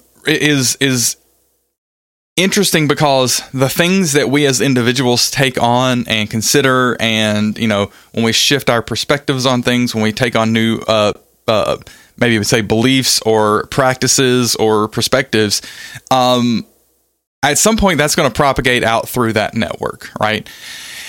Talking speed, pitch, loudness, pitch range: 150 wpm, 125 Hz, -13 LUFS, 110-140 Hz